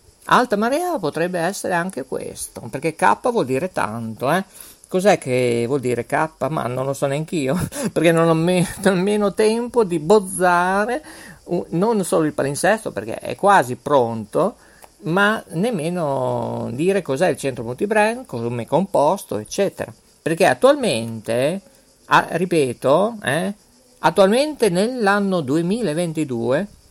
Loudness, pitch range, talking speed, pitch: -20 LUFS, 135-200 Hz, 130 wpm, 170 Hz